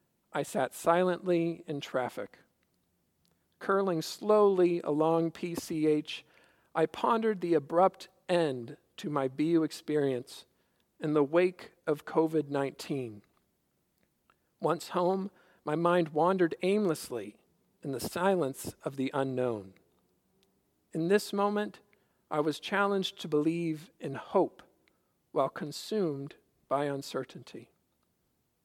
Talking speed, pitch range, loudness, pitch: 105 wpm, 150-185 Hz, -31 LUFS, 165 Hz